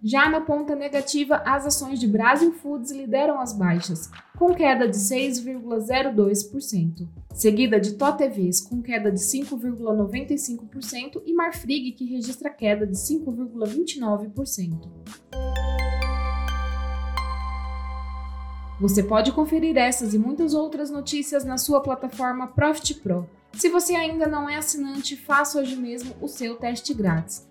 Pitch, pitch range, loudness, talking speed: 250 Hz, 205-285 Hz, -24 LUFS, 125 wpm